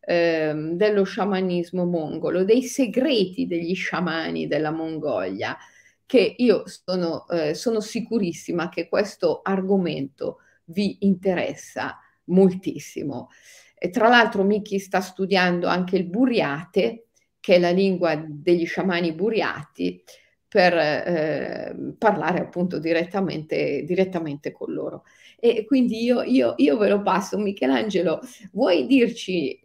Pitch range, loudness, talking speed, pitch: 170-215 Hz, -23 LUFS, 115 wpm, 185 Hz